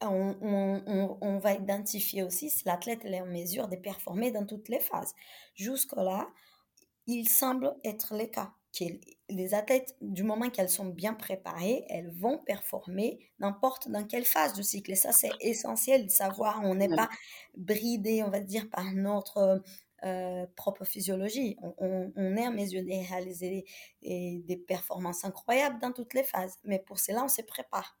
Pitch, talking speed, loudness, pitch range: 200 Hz, 175 wpm, -31 LUFS, 190-225 Hz